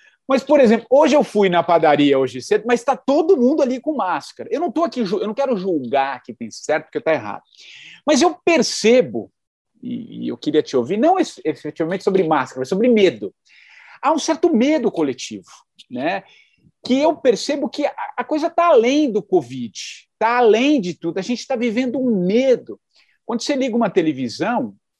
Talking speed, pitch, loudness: 185 wpm, 240 Hz, -18 LUFS